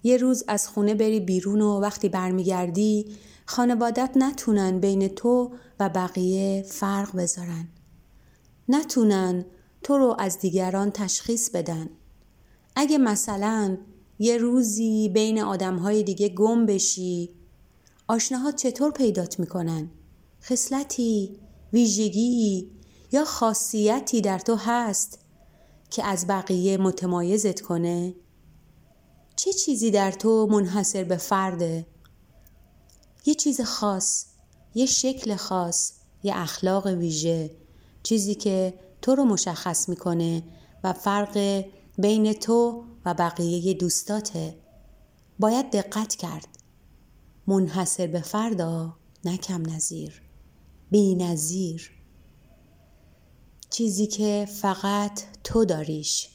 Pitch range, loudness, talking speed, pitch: 180-220 Hz, -24 LUFS, 100 wpm, 200 Hz